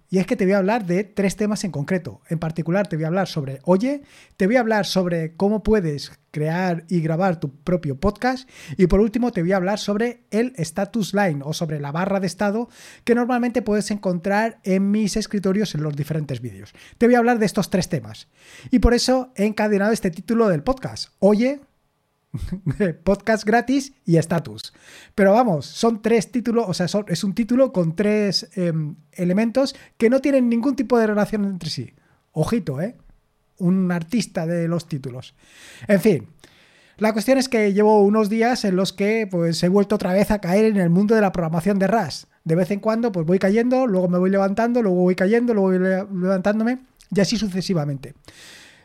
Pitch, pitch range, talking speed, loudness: 195 Hz, 175-220 Hz, 200 wpm, -21 LUFS